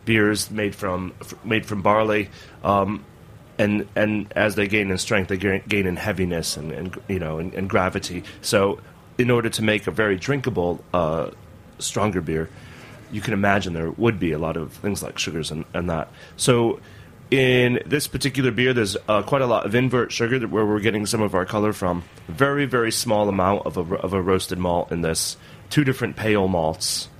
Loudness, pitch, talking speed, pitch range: -22 LUFS, 105 Hz, 195 wpm, 95-115 Hz